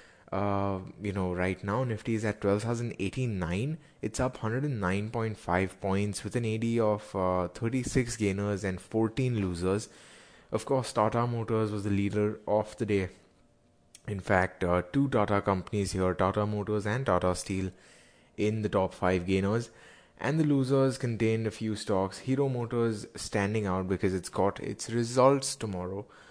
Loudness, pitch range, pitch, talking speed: -30 LUFS, 95-115 Hz, 105 Hz, 155 wpm